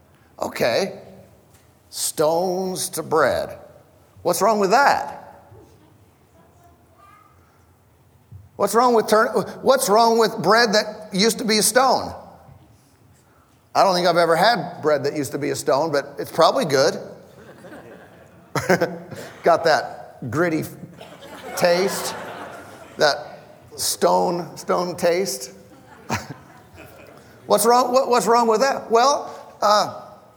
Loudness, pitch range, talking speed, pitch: -19 LUFS, 150-220 Hz, 110 wpm, 180 Hz